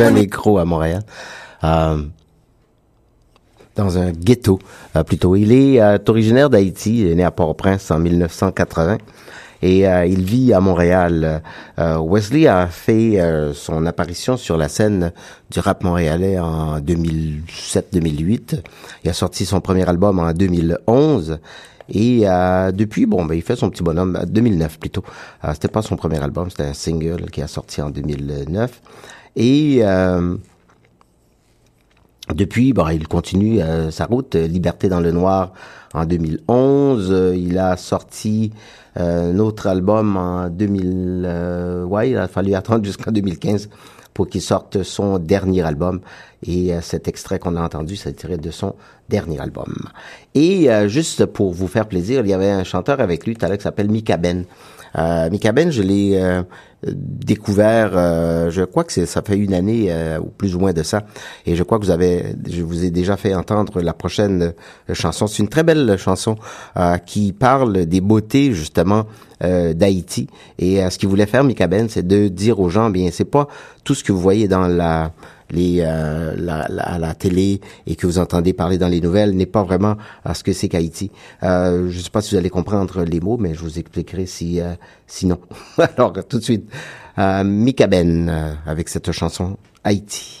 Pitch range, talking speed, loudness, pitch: 85-105 Hz, 180 wpm, -18 LUFS, 95 Hz